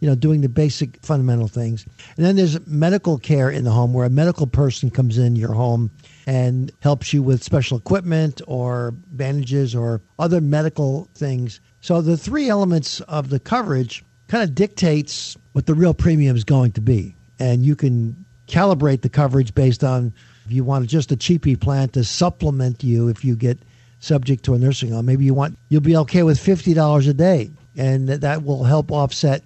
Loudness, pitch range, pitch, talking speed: -19 LUFS, 125-155 Hz, 140 Hz, 195 wpm